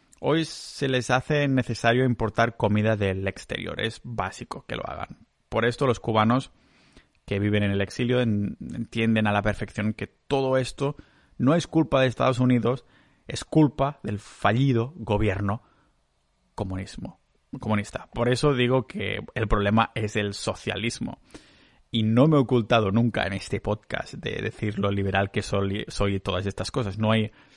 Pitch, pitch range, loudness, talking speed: 110 Hz, 100-130 Hz, -25 LUFS, 160 wpm